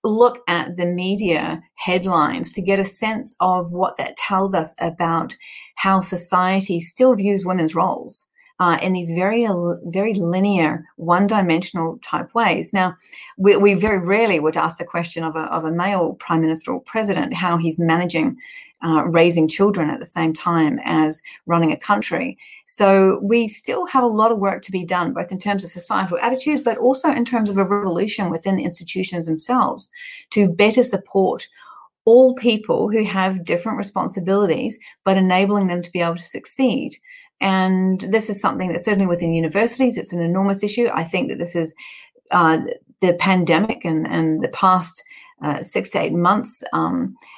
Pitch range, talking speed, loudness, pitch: 175-225 Hz, 175 wpm, -19 LUFS, 190 Hz